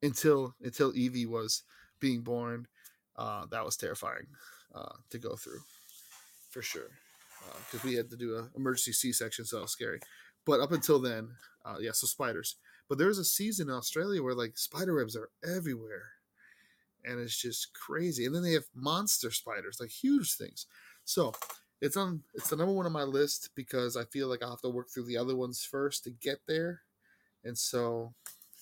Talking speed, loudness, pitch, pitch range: 195 wpm, -34 LUFS, 125 Hz, 120-155 Hz